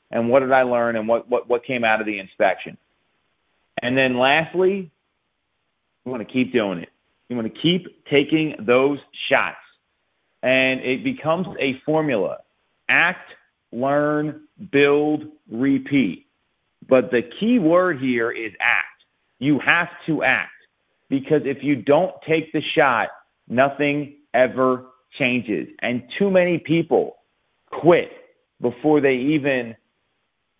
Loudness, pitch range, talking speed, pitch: -20 LUFS, 125-155 Hz, 135 wpm, 135 Hz